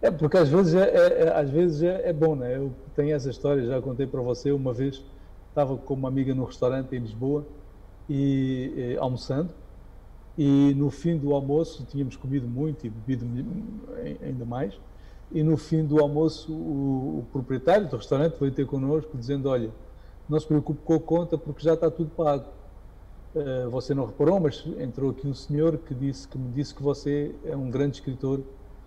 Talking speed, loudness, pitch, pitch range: 190 wpm, -26 LUFS, 140 Hz, 130-155 Hz